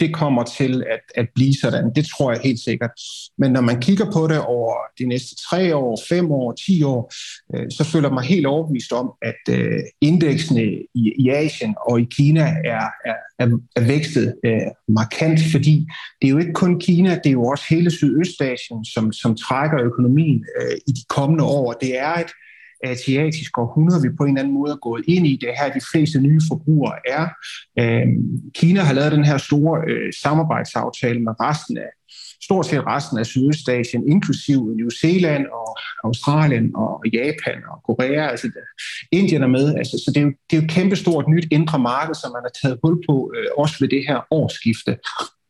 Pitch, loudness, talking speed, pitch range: 140 Hz, -19 LUFS, 185 wpm, 125-160 Hz